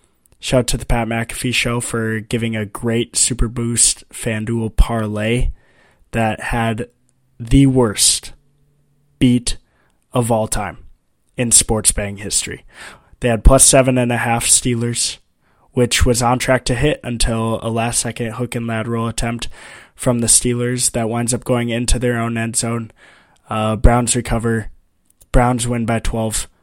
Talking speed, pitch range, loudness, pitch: 155 wpm, 110-125 Hz, -17 LUFS, 115 Hz